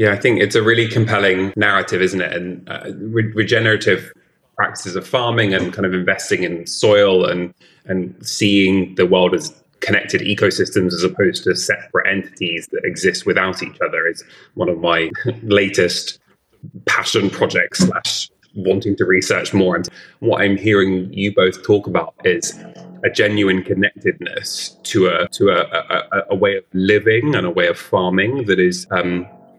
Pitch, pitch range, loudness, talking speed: 95 Hz, 90-105 Hz, -17 LUFS, 165 wpm